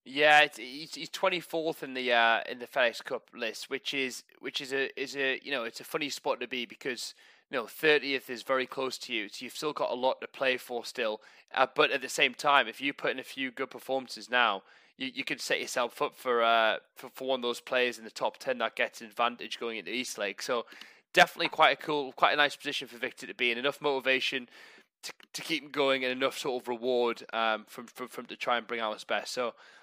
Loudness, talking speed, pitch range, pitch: -30 LUFS, 255 wpm, 120-140 Hz, 130 Hz